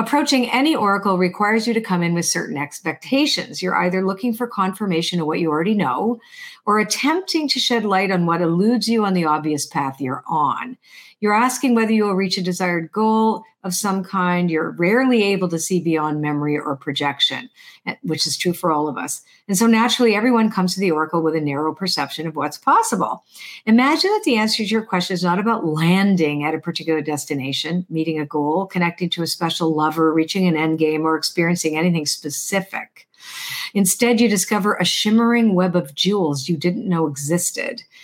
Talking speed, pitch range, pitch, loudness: 190 wpm, 160-220 Hz, 180 Hz, -19 LUFS